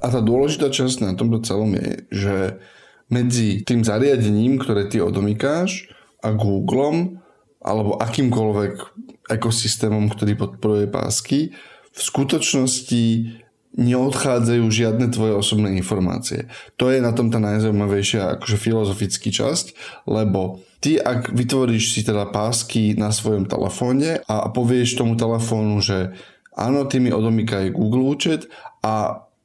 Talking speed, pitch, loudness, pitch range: 125 wpm, 115 Hz, -20 LUFS, 105-125 Hz